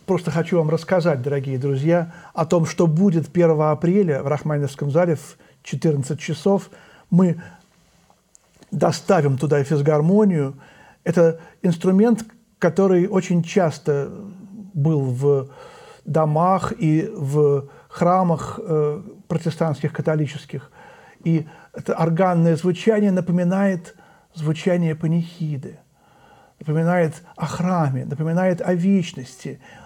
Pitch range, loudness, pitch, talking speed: 150-185 Hz, -20 LUFS, 165 Hz, 95 wpm